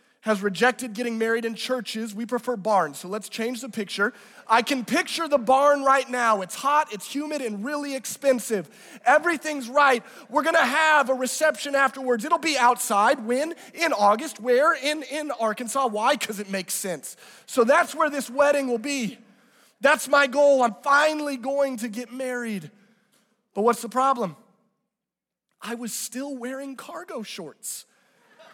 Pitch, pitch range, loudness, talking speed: 250 Hz, 220-285 Hz, -23 LUFS, 165 wpm